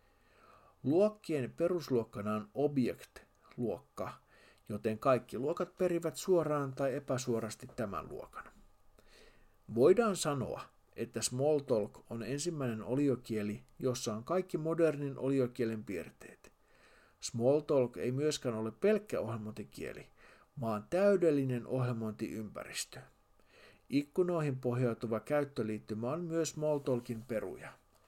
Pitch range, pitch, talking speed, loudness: 115-150 Hz, 130 Hz, 90 wpm, -35 LUFS